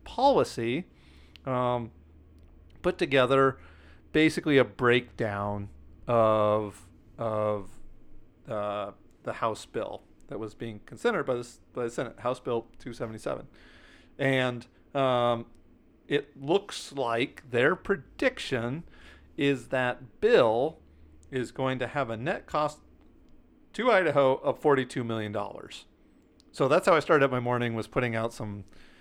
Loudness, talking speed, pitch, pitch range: -28 LUFS, 125 wpm, 115 Hz, 100-130 Hz